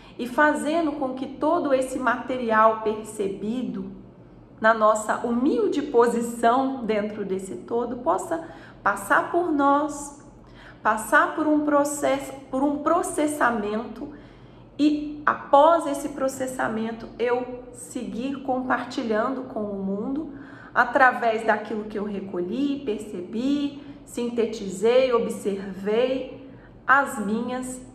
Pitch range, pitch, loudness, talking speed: 220-285 Hz, 250 Hz, -24 LUFS, 100 wpm